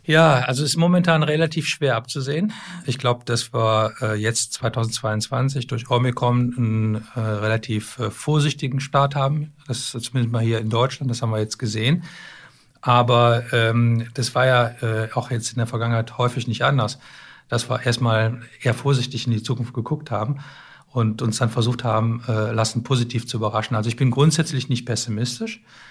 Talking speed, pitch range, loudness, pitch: 175 wpm, 115-135 Hz, -21 LUFS, 120 Hz